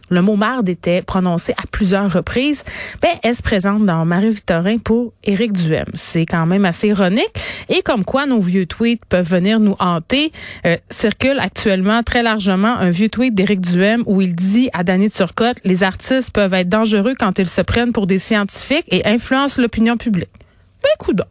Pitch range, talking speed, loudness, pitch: 185-235 Hz, 190 wpm, -16 LUFS, 205 Hz